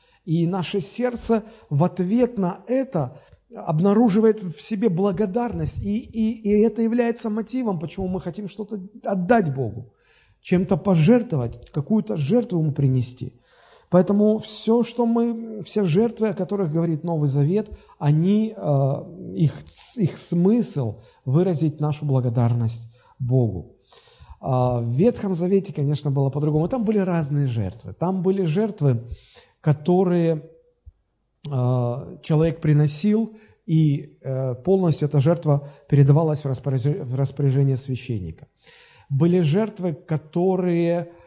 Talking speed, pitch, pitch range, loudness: 115 wpm, 170 Hz, 140-205 Hz, -22 LUFS